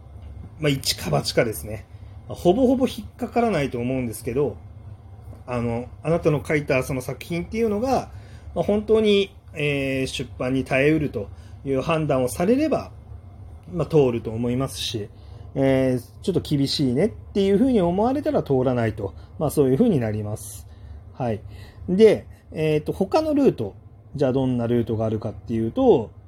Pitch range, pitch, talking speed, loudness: 105-155 Hz, 125 Hz, 350 characters per minute, -23 LUFS